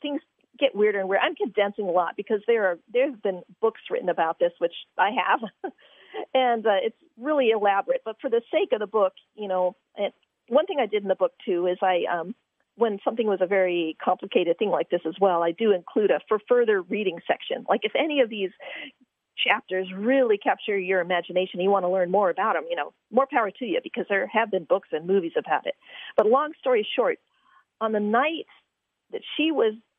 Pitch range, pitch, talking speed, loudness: 190-270 Hz, 215 Hz, 220 wpm, -25 LUFS